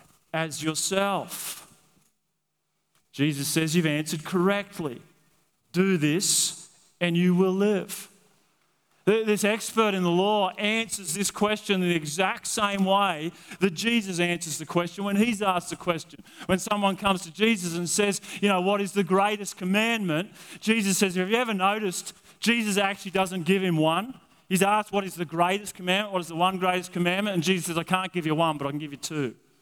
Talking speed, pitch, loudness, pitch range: 180 wpm, 190 Hz, -25 LUFS, 170-200 Hz